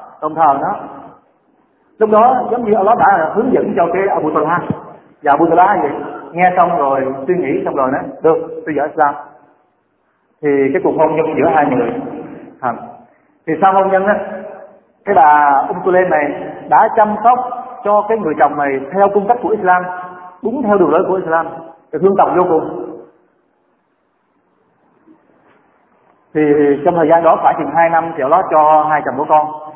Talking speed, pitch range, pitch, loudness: 180 wpm, 155-200 Hz, 165 Hz, -13 LUFS